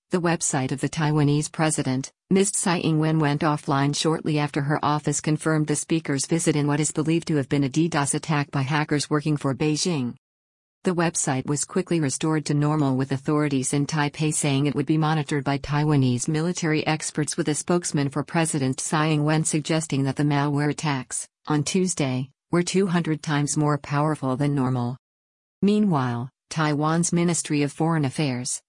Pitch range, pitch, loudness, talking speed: 140-160 Hz, 150 Hz, -23 LUFS, 170 wpm